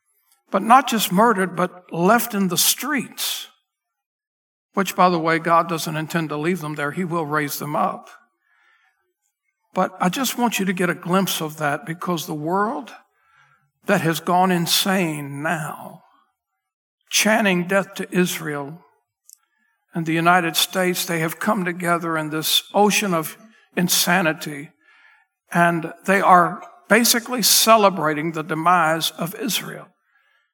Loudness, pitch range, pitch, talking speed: -19 LUFS, 165-205 Hz, 180 Hz, 140 wpm